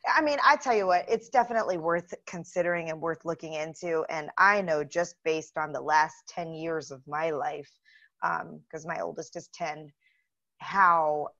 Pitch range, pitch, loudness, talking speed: 155-180 Hz, 165 Hz, -28 LUFS, 180 wpm